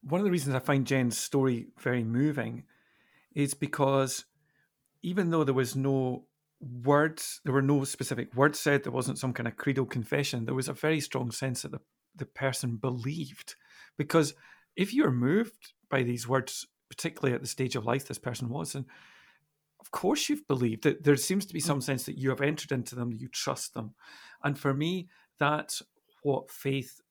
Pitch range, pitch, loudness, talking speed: 130-150 Hz, 135 Hz, -30 LUFS, 190 wpm